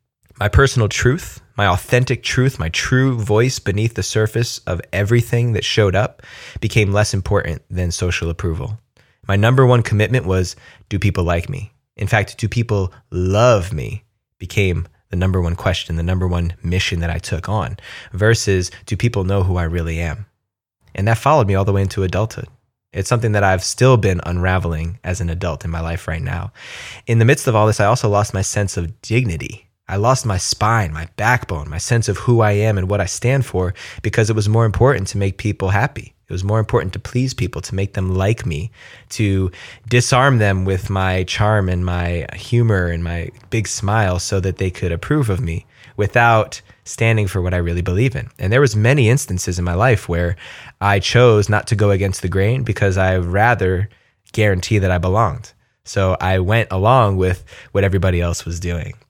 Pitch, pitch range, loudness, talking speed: 100 Hz, 90-115 Hz, -18 LUFS, 200 wpm